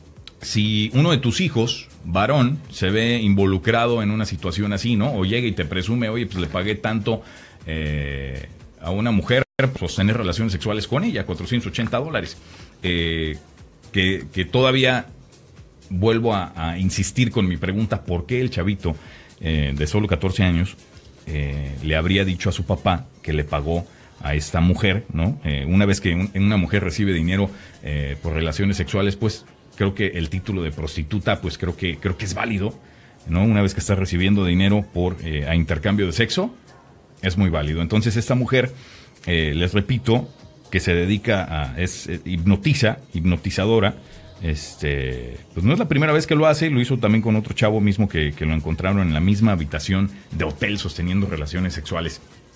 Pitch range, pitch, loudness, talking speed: 85-110 Hz, 95 Hz, -21 LUFS, 180 wpm